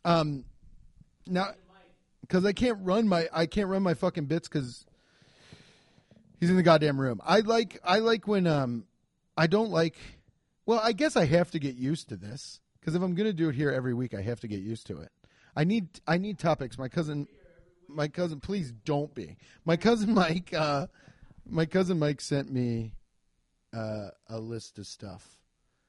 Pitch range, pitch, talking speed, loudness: 125-185 Hz, 160 Hz, 185 wpm, -29 LUFS